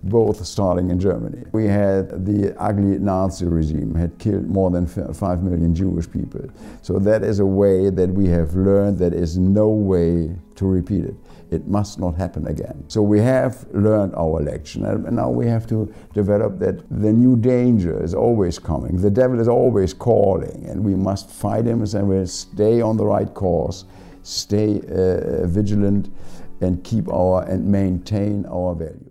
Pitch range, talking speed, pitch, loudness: 90-105 Hz, 175 wpm, 95 Hz, -19 LUFS